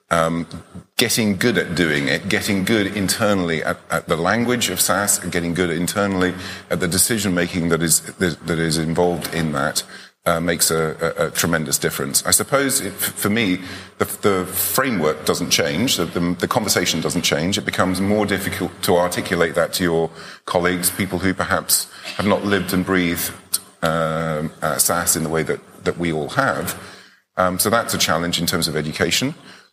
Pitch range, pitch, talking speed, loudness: 85-95 Hz, 90 Hz, 185 wpm, -19 LUFS